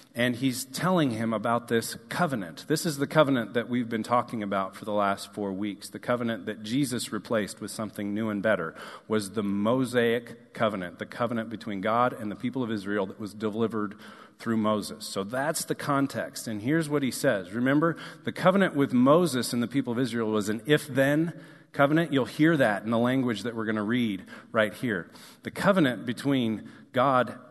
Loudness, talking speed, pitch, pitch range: -27 LUFS, 195 wpm, 120 Hz, 110-135 Hz